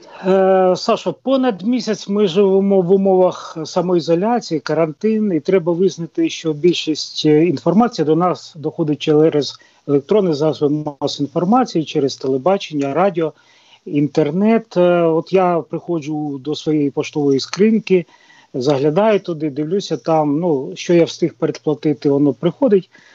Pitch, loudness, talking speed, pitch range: 165 Hz, -17 LUFS, 115 wpm, 150-190 Hz